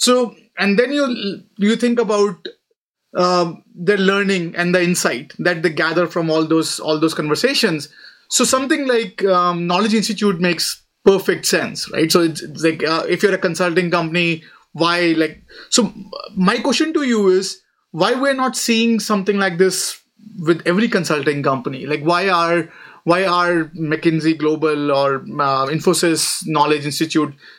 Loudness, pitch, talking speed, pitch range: -17 LUFS, 180 Hz, 160 wpm, 160-210 Hz